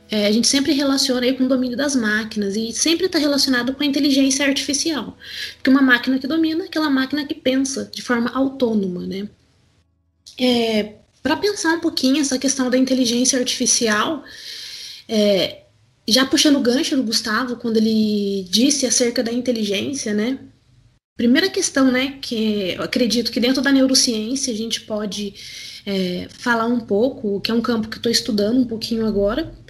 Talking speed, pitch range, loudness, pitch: 170 wpm, 215-270 Hz, -19 LUFS, 245 Hz